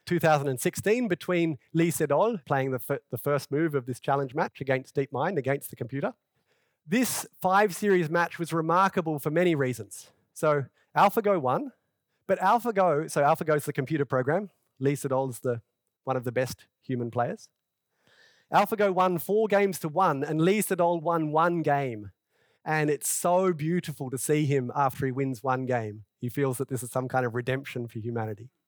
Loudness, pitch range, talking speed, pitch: -27 LUFS, 130-175 Hz, 175 wpm, 150 Hz